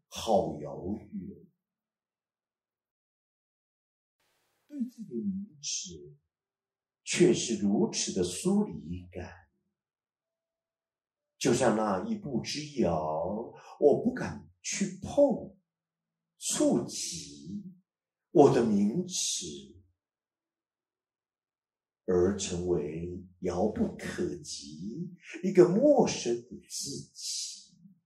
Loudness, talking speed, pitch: -30 LUFS, 105 characters per minute, 180 Hz